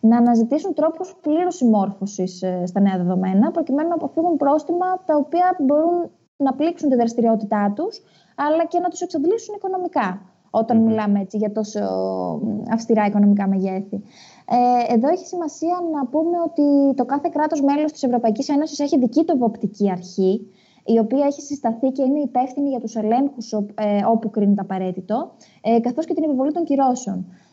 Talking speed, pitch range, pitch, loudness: 155 wpm, 210-310 Hz, 250 Hz, -20 LUFS